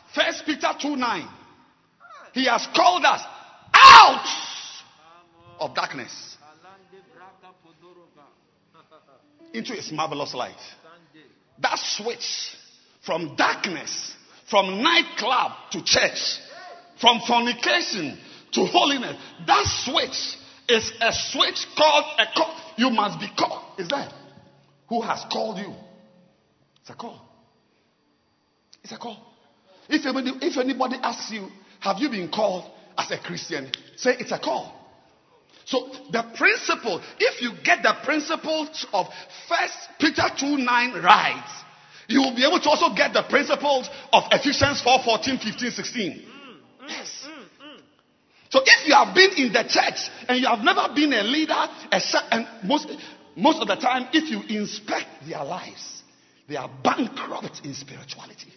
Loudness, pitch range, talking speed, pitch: -21 LUFS, 220-305 Hz, 130 wpm, 255 Hz